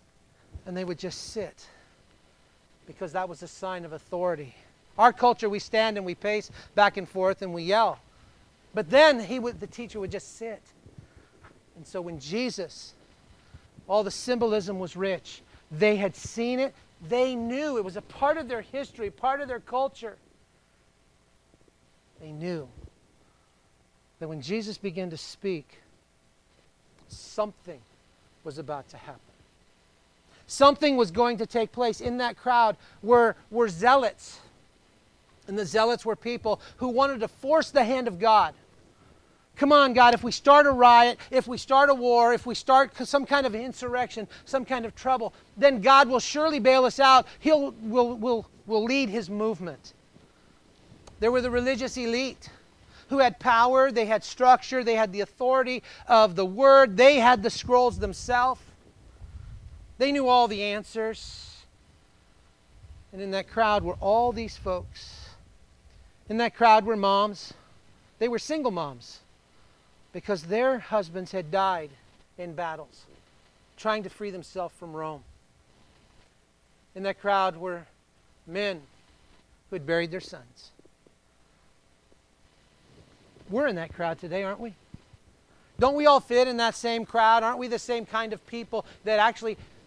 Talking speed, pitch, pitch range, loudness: 155 wpm, 215 Hz, 170-245 Hz, -24 LUFS